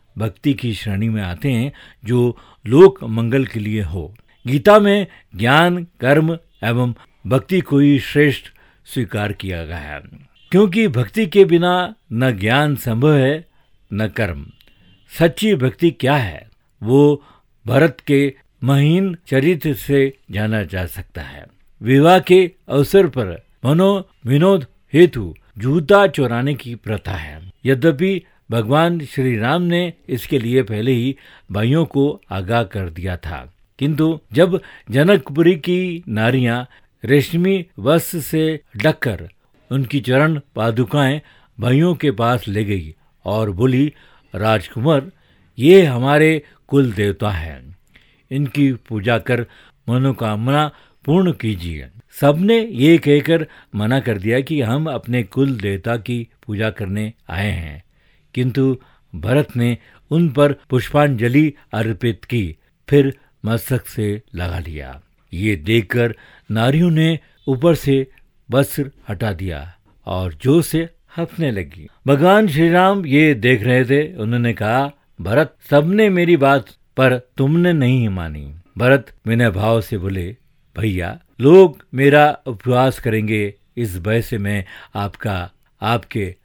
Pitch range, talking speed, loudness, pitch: 110-150 Hz, 125 wpm, -17 LUFS, 130 Hz